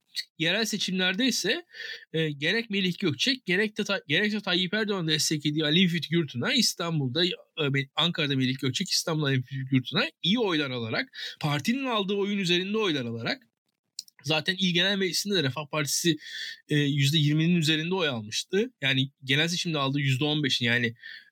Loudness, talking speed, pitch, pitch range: -26 LUFS, 150 wpm, 165 Hz, 145-200 Hz